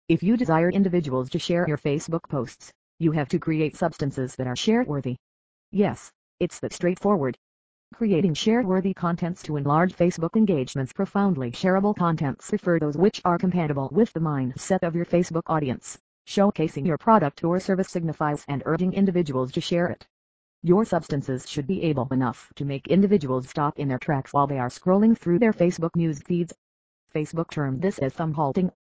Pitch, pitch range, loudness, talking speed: 165 Hz, 140-185 Hz, -24 LUFS, 170 wpm